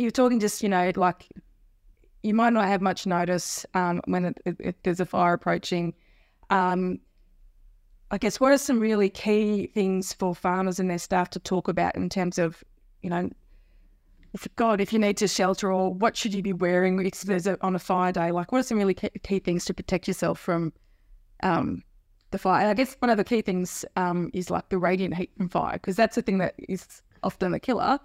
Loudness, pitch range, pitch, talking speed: -26 LUFS, 175-205 Hz, 185 Hz, 215 wpm